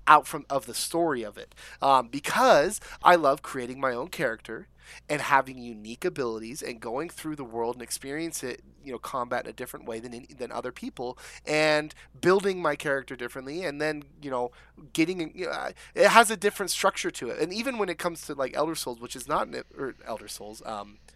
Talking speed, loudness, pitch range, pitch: 210 wpm, -27 LUFS, 125-165 Hz, 145 Hz